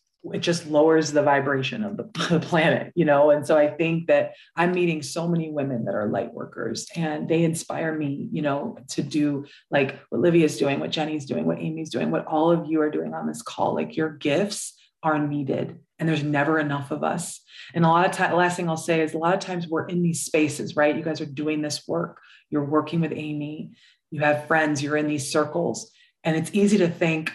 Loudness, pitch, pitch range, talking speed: -24 LUFS, 155 Hz, 150-165 Hz, 230 wpm